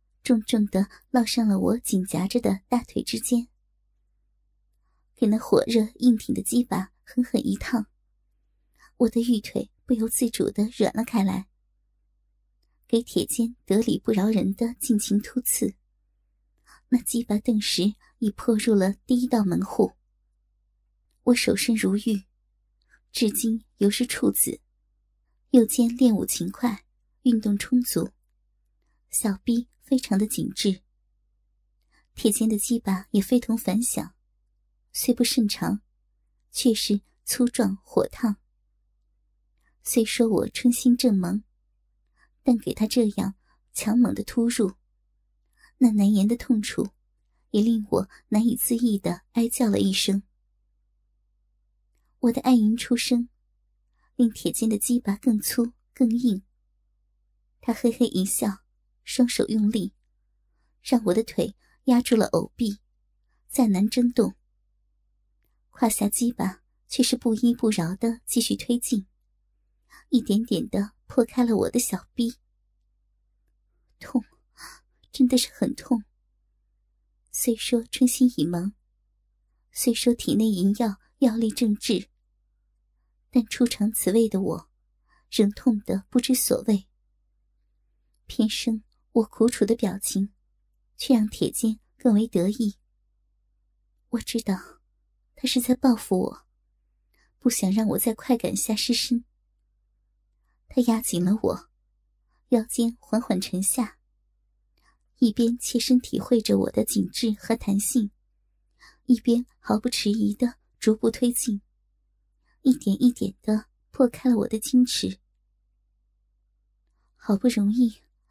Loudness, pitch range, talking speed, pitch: -24 LUFS, 205-245 Hz, 170 characters per minute, 230 Hz